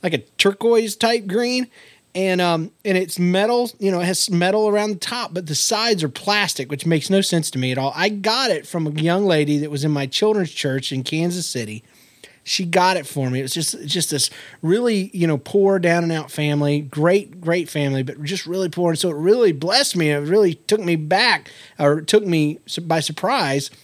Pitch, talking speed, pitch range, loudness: 175 Hz, 225 wpm, 150-195 Hz, -19 LUFS